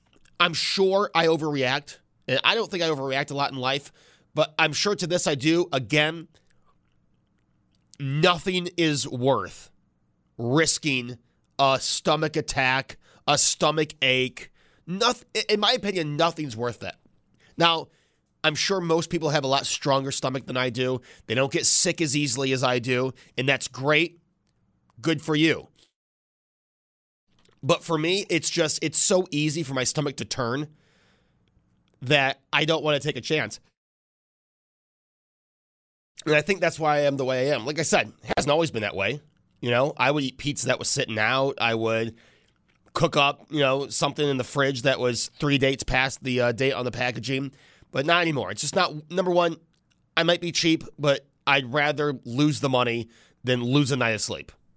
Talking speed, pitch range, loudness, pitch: 180 wpm, 130-160 Hz, -24 LUFS, 145 Hz